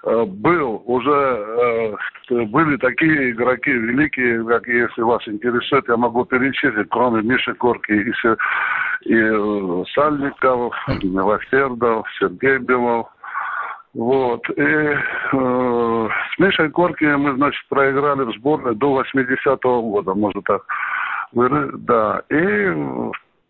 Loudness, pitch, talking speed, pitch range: -18 LUFS, 125 Hz, 105 wpm, 115-135 Hz